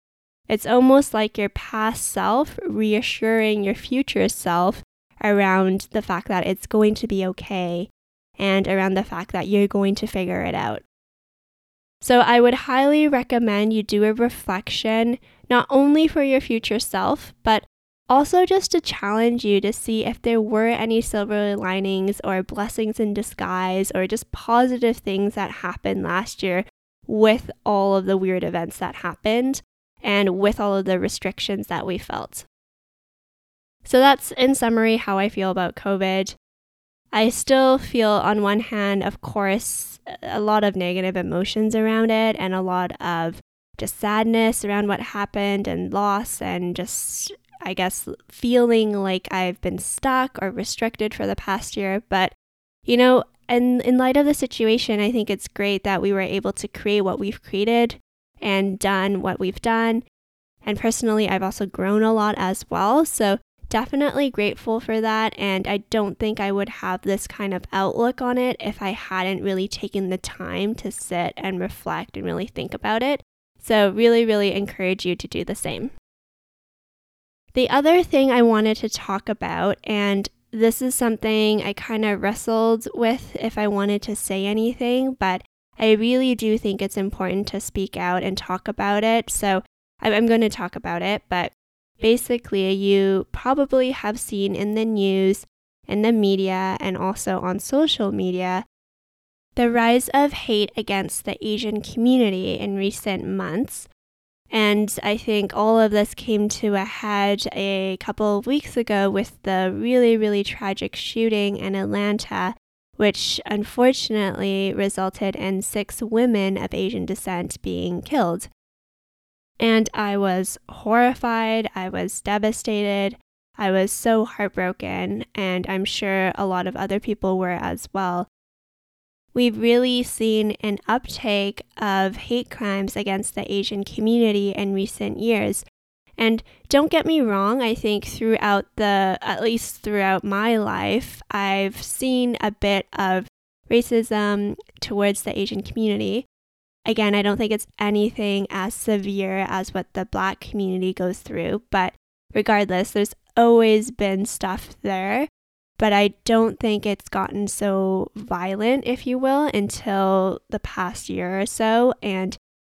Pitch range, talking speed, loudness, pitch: 195-230 Hz, 155 wpm, -22 LUFS, 210 Hz